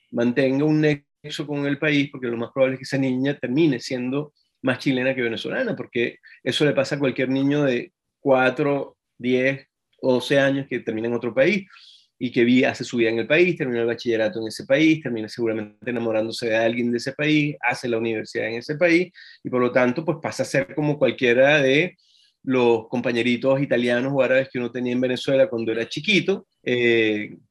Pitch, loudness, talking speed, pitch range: 130 Hz, -22 LUFS, 200 wpm, 120-145 Hz